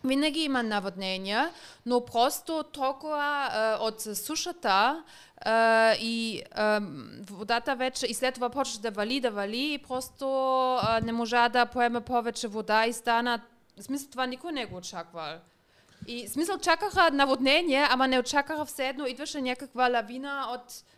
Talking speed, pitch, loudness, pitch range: 145 wpm, 250 Hz, -28 LUFS, 225-275 Hz